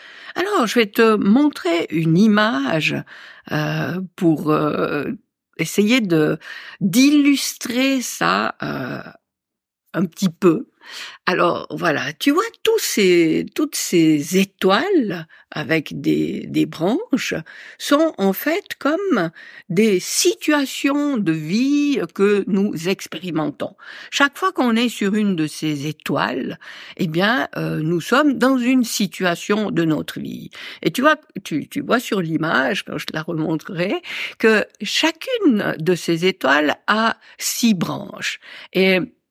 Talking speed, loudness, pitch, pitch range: 125 wpm, -19 LUFS, 210 Hz, 170-280 Hz